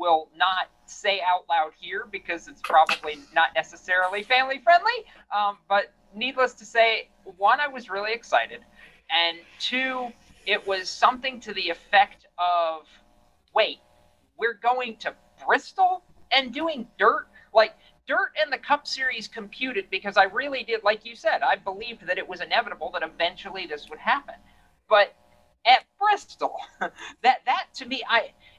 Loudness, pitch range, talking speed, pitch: -24 LUFS, 180-260 Hz, 155 wpm, 220 Hz